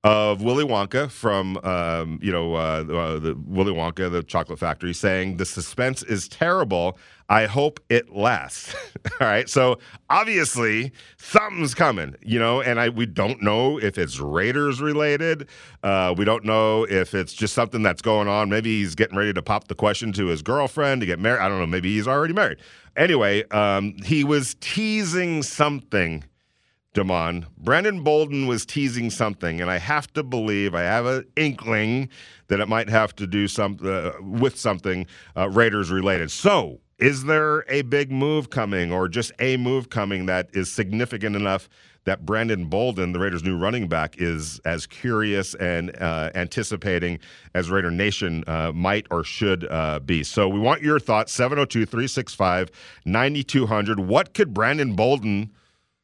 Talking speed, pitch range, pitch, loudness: 170 wpm, 95-125 Hz, 105 Hz, -22 LUFS